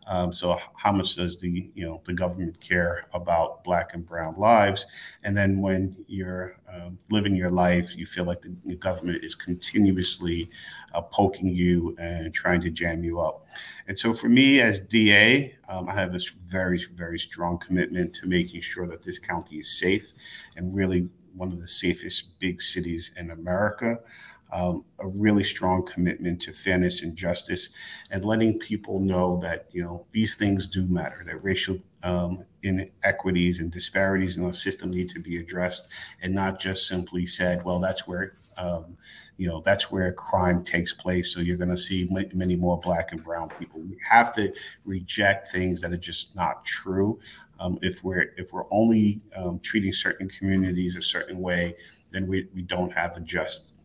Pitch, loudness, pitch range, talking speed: 90 Hz, -25 LUFS, 90-95 Hz, 180 wpm